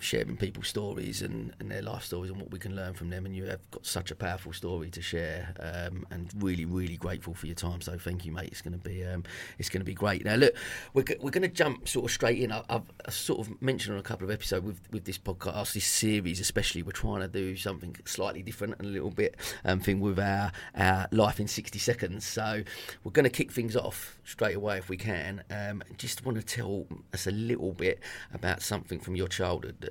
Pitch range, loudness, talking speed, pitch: 90-105 Hz, -32 LUFS, 245 wpm, 95 Hz